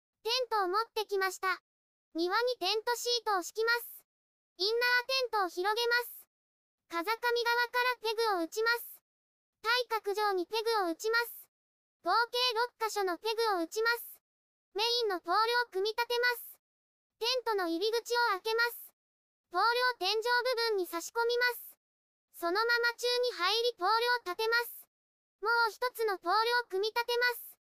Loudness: -31 LUFS